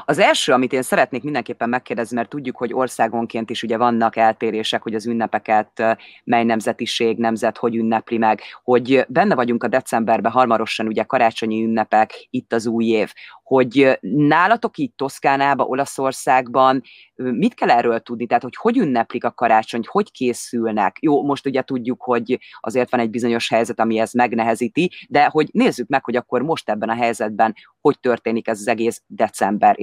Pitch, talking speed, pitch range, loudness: 120 Hz, 170 wpm, 115-130 Hz, -19 LUFS